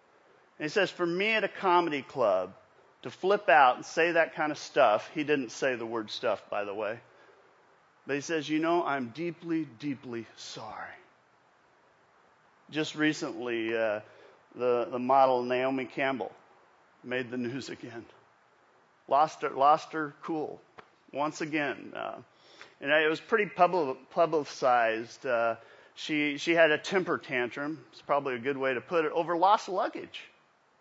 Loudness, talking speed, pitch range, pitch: -29 LUFS, 155 wpm, 125-165 Hz, 150 Hz